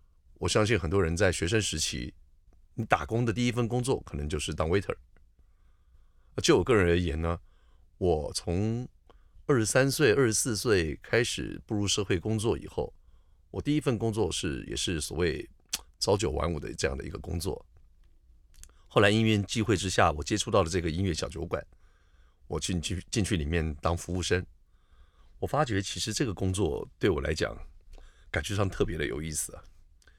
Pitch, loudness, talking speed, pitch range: 85 Hz, -29 LUFS, 270 characters per minute, 75-100 Hz